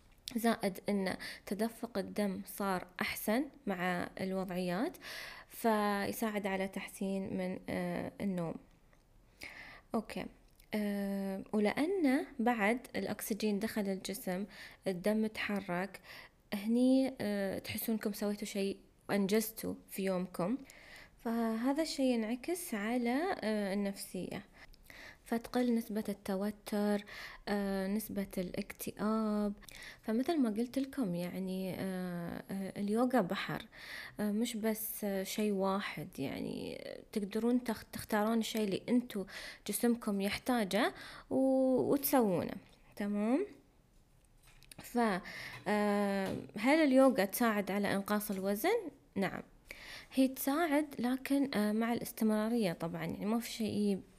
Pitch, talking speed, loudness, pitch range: 210 Hz, 85 wpm, -36 LUFS, 195-235 Hz